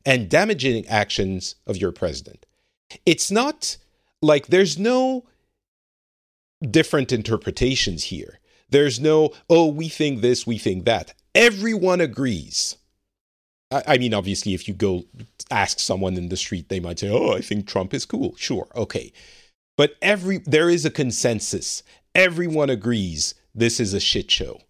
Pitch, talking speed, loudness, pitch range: 125 Hz, 150 wpm, -21 LUFS, 100-160 Hz